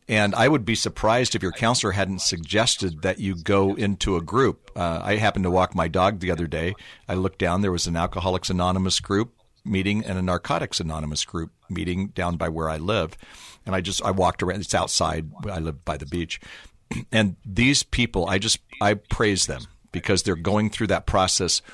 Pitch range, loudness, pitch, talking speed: 85-105 Hz, -23 LUFS, 95 Hz, 205 wpm